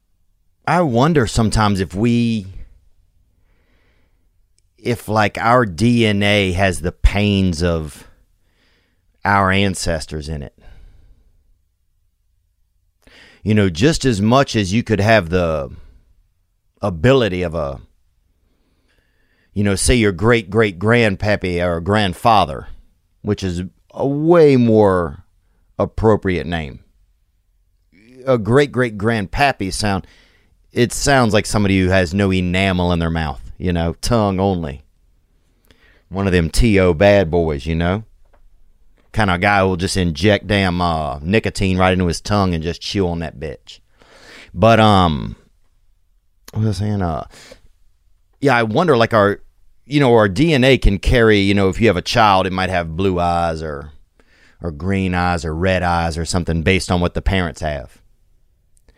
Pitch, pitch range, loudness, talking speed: 95 Hz, 85-105 Hz, -16 LUFS, 140 wpm